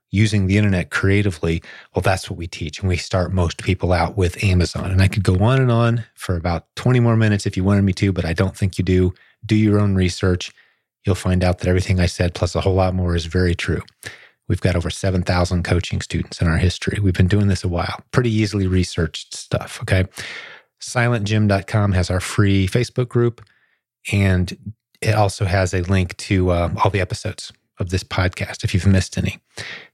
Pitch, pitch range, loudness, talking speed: 95 Hz, 90-105 Hz, -19 LUFS, 205 wpm